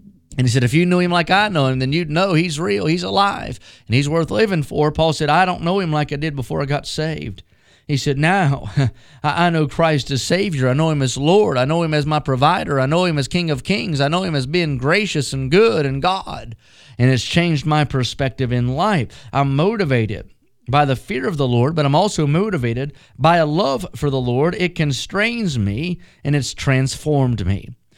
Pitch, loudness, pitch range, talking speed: 150 Hz, -18 LUFS, 130-170 Hz, 225 wpm